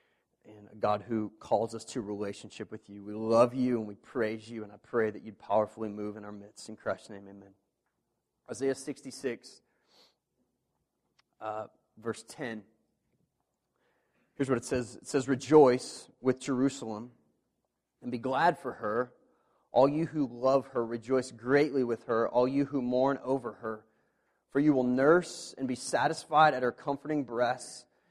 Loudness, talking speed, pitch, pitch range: -30 LUFS, 160 wpm, 120 Hz, 110-135 Hz